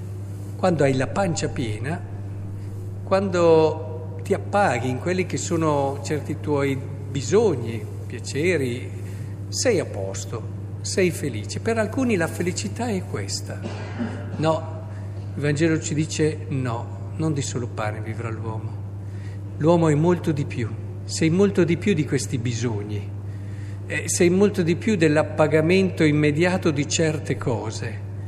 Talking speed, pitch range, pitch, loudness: 125 wpm, 100-150 Hz, 110 Hz, -23 LUFS